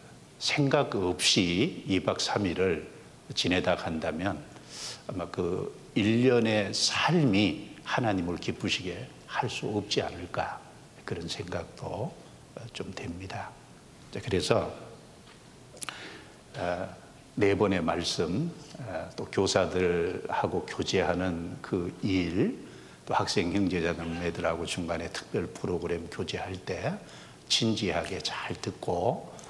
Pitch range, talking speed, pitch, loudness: 85-110 Hz, 190 characters per minute, 95 Hz, -30 LUFS